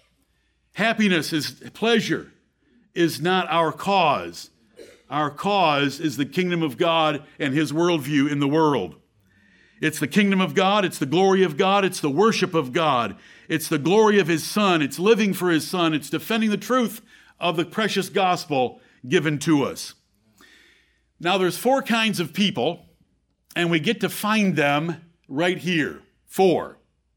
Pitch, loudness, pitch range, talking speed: 175 Hz, -22 LUFS, 155-200 Hz, 160 wpm